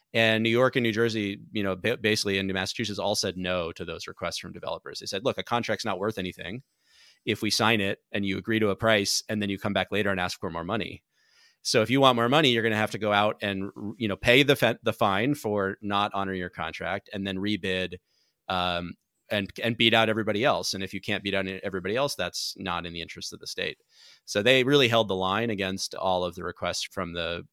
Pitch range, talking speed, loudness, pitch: 95-115 Hz, 245 wpm, -26 LUFS, 105 Hz